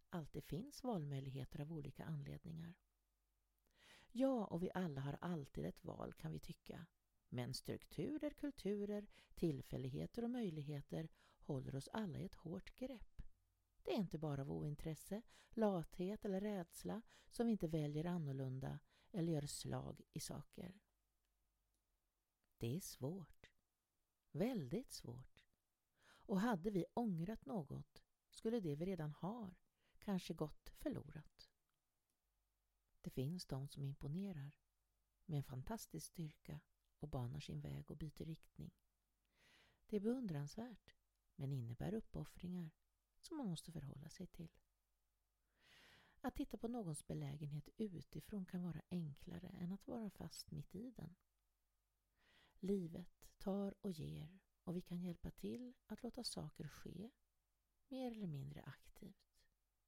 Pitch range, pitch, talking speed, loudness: 145-200 Hz, 170 Hz, 130 wpm, -48 LUFS